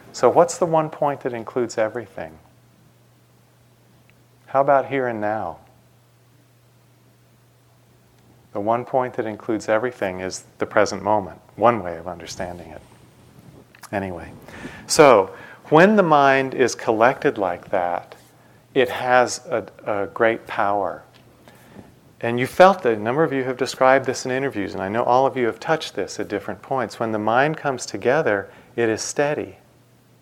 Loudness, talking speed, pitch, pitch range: -20 LUFS, 150 wpm, 120 Hz, 105-135 Hz